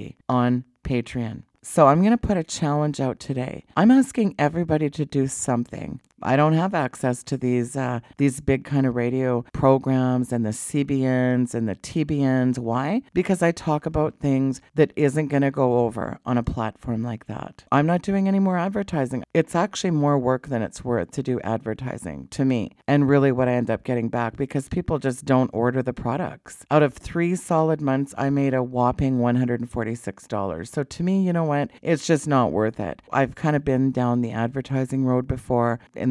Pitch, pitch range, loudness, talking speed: 130 Hz, 120-150 Hz, -23 LUFS, 195 wpm